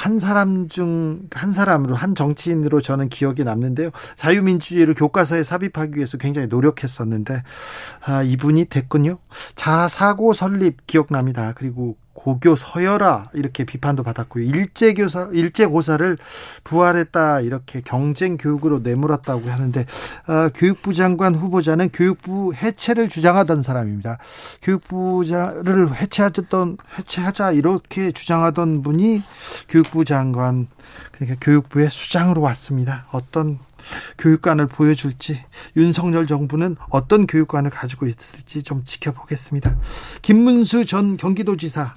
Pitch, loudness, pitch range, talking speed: 155 Hz, -19 LUFS, 135-180 Hz, 325 characters per minute